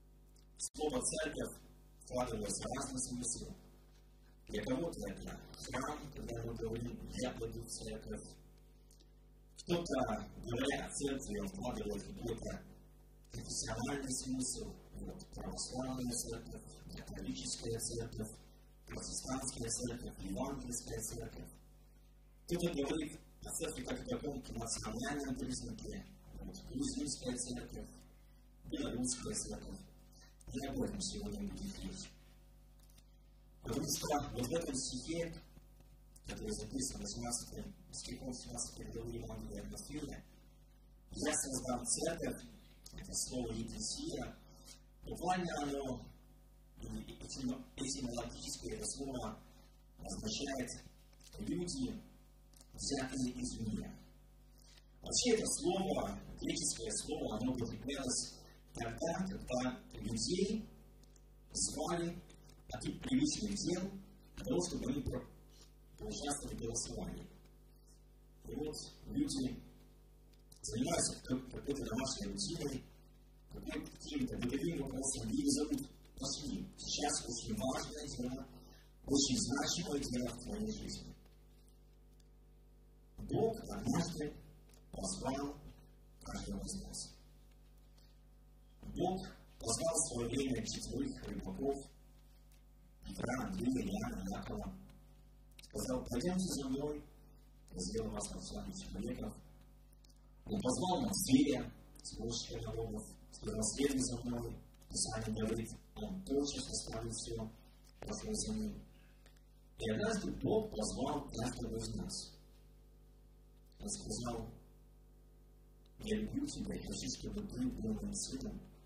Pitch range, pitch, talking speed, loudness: 115-150 Hz, 130 Hz, 95 wpm, -41 LUFS